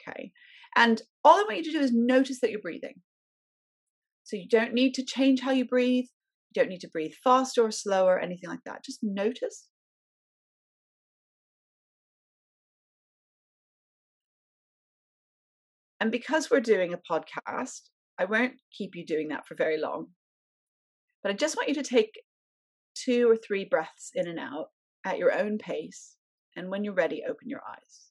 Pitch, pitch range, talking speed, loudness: 245 Hz, 205-270 Hz, 160 wpm, -27 LUFS